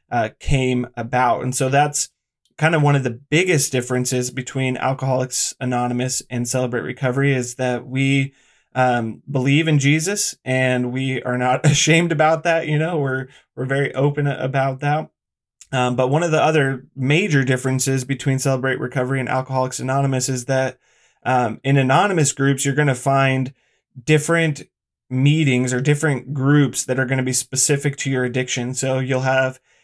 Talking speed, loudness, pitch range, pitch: 165 wpm, -19 LUFS, 130-145 Hz, 130 Hz